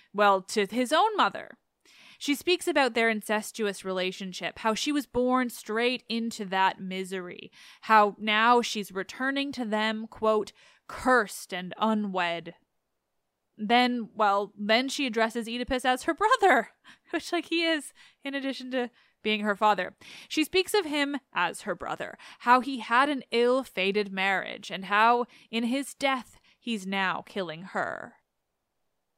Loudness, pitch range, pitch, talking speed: -27 LUFS, 205-260 Hz, 230 Hz, 145 wpm